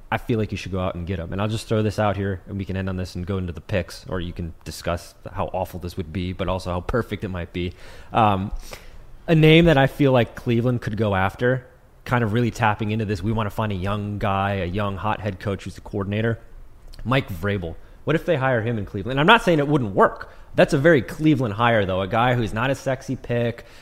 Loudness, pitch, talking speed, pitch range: -22 LUFS, 105 Hz, 265 wpm, 95-120 Hz